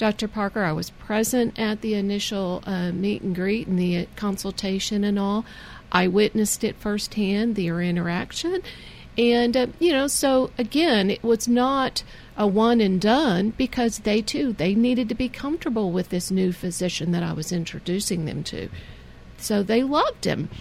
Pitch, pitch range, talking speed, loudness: 210 Hz, 185-235 Hz, 170 wpm, -23 LUFS